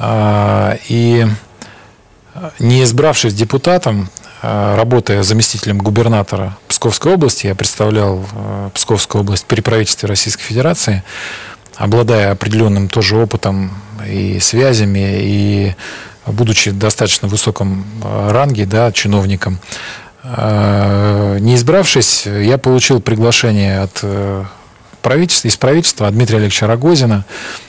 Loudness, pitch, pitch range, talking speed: -12 LUFS, 105 Hz, 100-120 Hz, 95 wpm